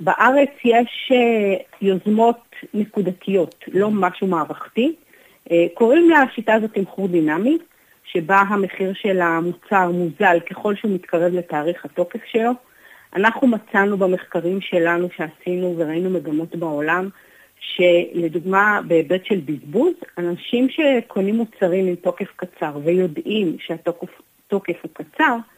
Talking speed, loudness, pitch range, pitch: 105 wpm, -19 LUFS, 175-220 Hz, 190 Hz